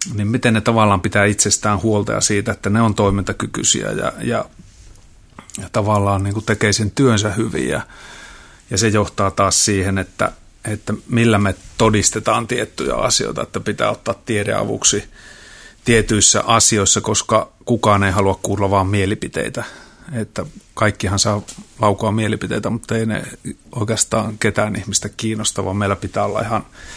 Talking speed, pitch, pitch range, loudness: 150 wpm, 105 Hz, 100-110 Hz, -17 LUFS